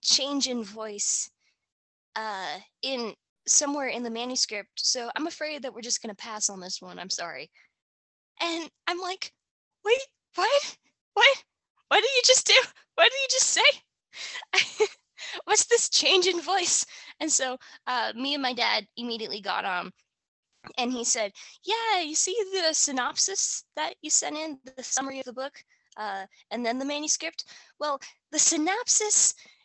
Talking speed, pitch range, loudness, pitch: 160 wpm, 245-380 Hz, -25 LUFS, 295 Hz